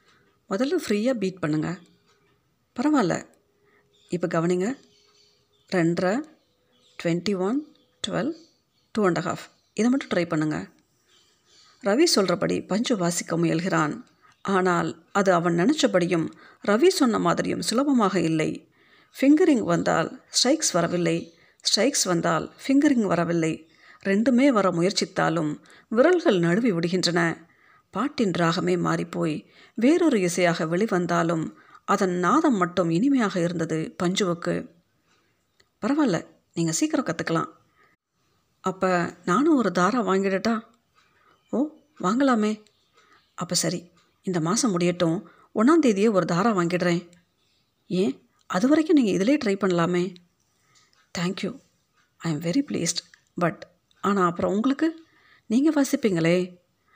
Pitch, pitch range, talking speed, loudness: 185 Hz, 175-260 Hz, 100 wpm, -24 LUFS